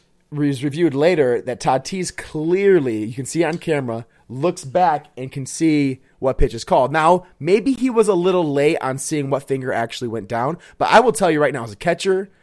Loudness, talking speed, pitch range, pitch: -19 LUFS, 215 wpm, 130-180 Hz, 150 Hz